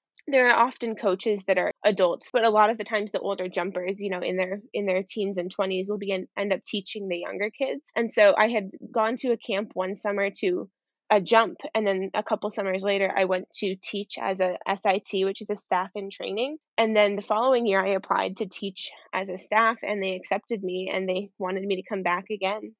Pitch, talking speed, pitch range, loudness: 200 Hz, 235 wpm, 190-220 Hz, -26 LUFS